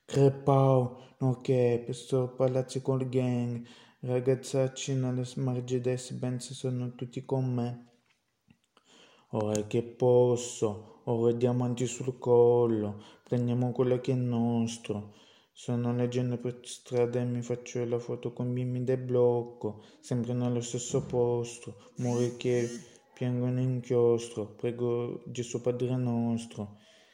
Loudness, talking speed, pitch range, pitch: -30 LUFS, 120 wpm, 120-125 Hz, 125 Hz